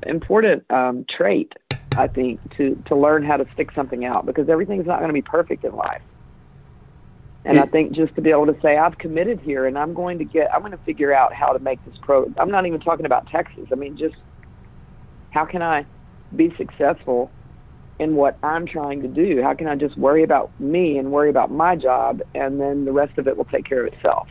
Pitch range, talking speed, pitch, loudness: 135-165 Hz, 225 wpm, 150 Hz, -20 LUFS